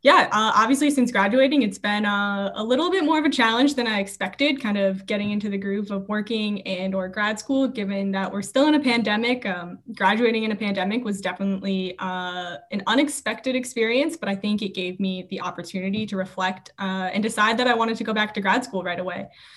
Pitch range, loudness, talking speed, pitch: 190-235 Hz, -23 LUFS, 220 wpm, 210 Hz